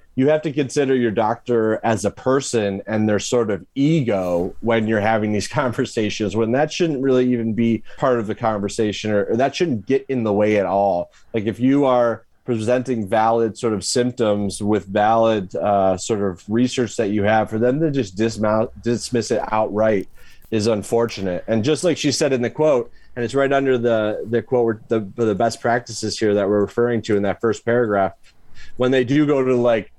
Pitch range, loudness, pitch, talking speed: 105-125 Hz, -20 LUFS, 115 Hz, 205 wpm